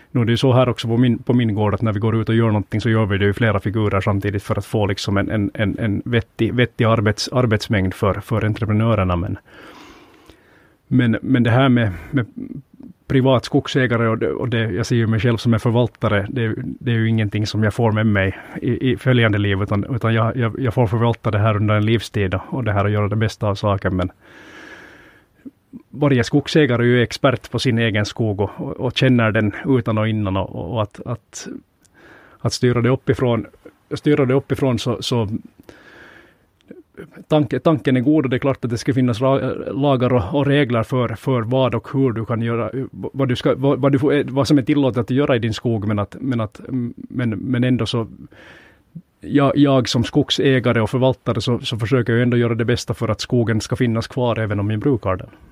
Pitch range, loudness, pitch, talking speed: 110-130 Hz, -19 LUFS, 115 Hz, 215 wpm